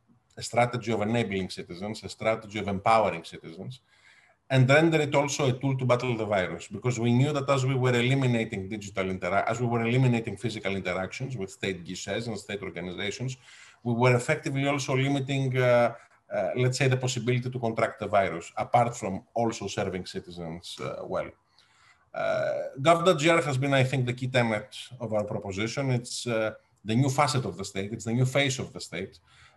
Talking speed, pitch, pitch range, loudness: 185 wpm, 120 Hz, 110-135 Hz, -27 LUFS